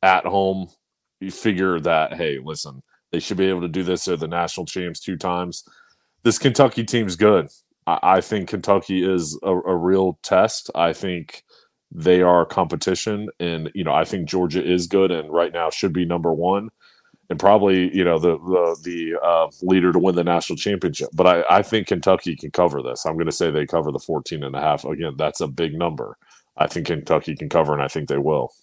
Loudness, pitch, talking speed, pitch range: -20 LUFS, 90 Hz, 210 wpm, 85-95 Hz